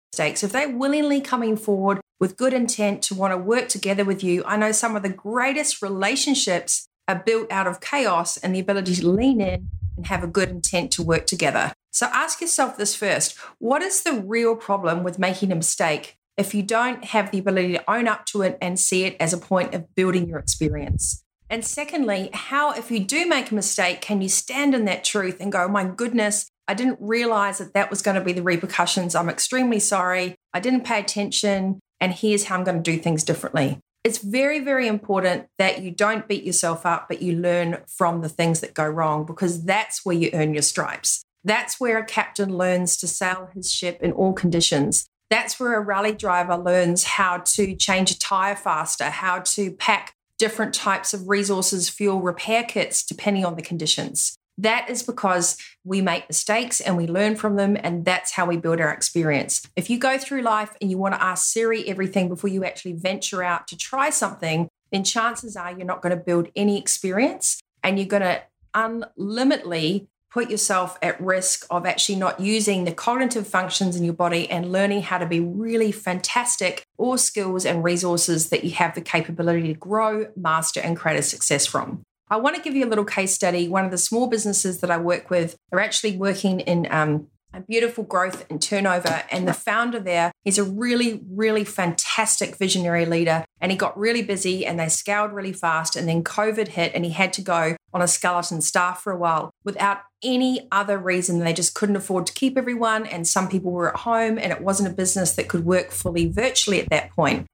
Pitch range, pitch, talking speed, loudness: 175-215 Hz, 190 Hz, 210 wpm, -22 LUFS